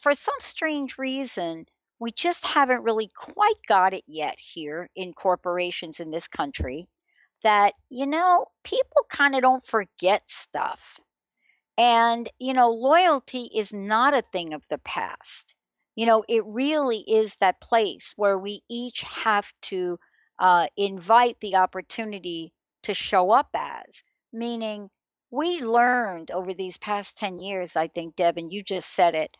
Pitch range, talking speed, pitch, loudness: 185-255 Hz, 150 wpm, 220 Hz, -24 LUFS